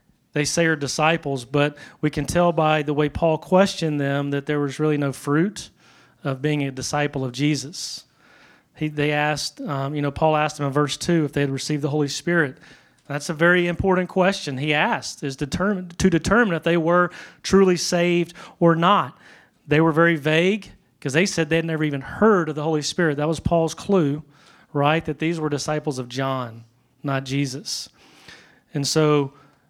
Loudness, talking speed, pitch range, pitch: -22 LUFS, 190 wpm, 145-170 Hz, 150 Hz